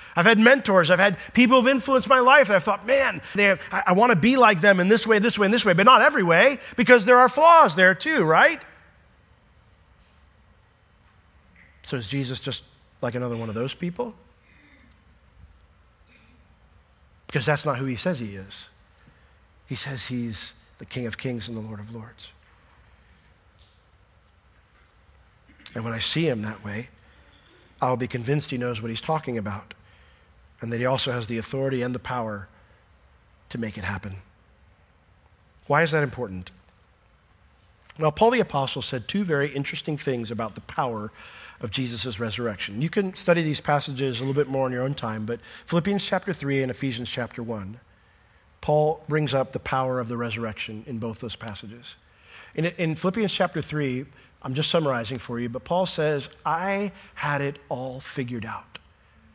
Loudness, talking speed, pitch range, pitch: -23 LUFS, 175 wpm, 95-155 Hz, 120 Hz